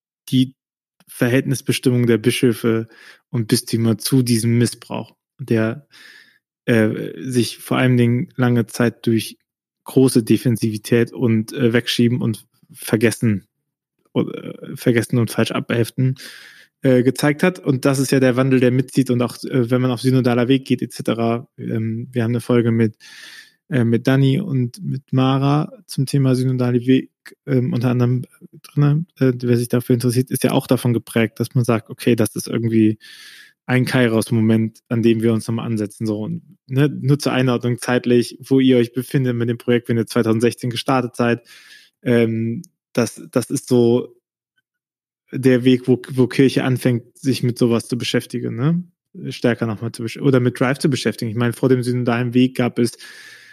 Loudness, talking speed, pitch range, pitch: -19 LUFS, 165 wpm, 115-130 Hz, 125 Hz